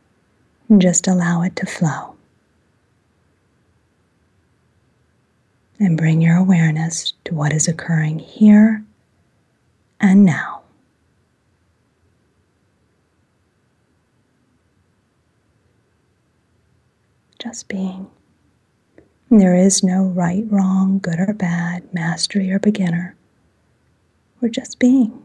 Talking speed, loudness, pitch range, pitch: 80 wpm, -16 LUFS, 160-200 Hz, 180 Hz